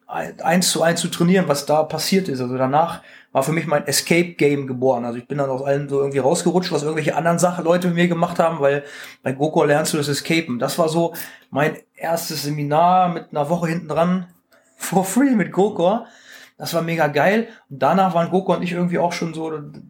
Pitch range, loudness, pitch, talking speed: 145-175 Hz, -19 LUFS, 165 Hz, 215 wpm